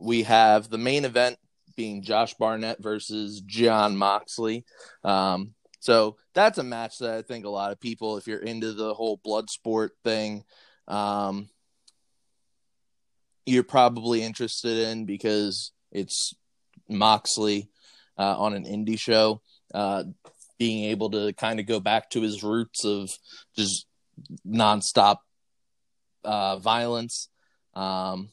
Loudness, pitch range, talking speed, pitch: -25 LUFS, 105-115 Hz, 130 wpm, 110 Hz